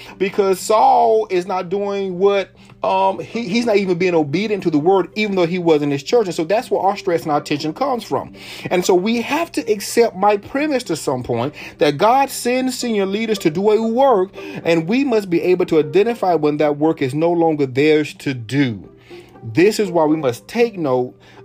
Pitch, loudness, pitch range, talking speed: 190 Hz, -17 LUFS, 160-220 Hz, 215 wpm